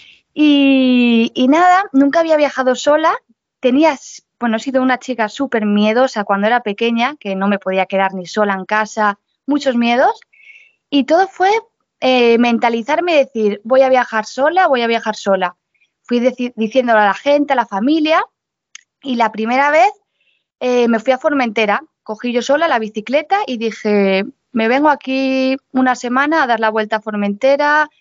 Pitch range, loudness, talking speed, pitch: 220-285 Hz, -15 LUFS, 170 wpm, 255 Hz